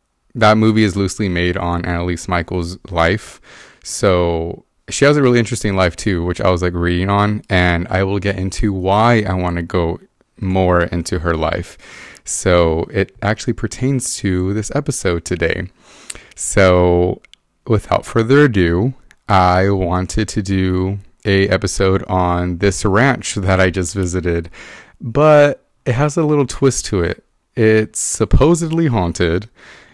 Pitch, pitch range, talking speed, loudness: 95 Hz, 90-110 Hz, 145 wpm, -16 LUFS